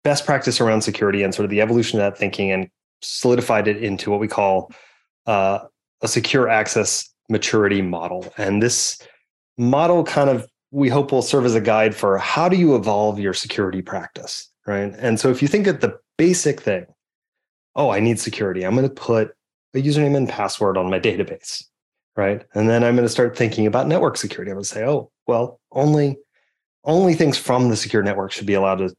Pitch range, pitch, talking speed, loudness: 100-135 Hz, 115 Hz, 205 wpm, -19 LUFS